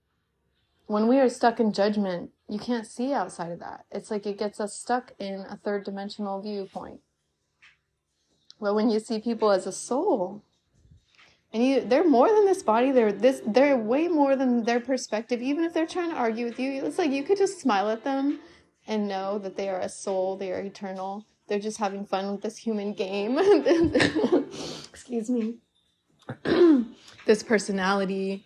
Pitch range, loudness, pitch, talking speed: 195-250 Hz, -26 LUFS, 215 Hz, 180 wpm